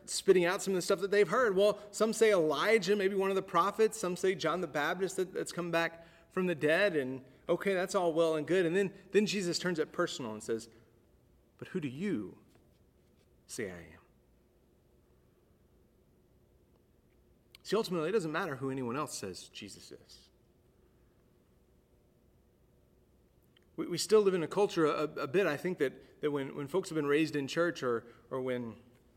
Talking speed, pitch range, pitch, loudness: 180 wpm, 145-195 Hz, 170 Hz, -32 LUFS